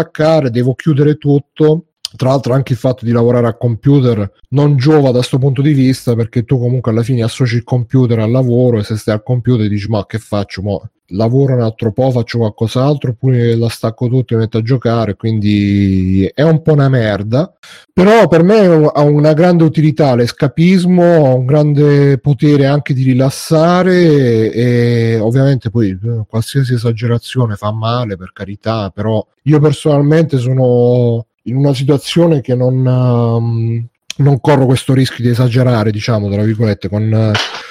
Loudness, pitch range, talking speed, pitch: -12 LUFS, 115-145 Hz, 165 wpm, 125 Hz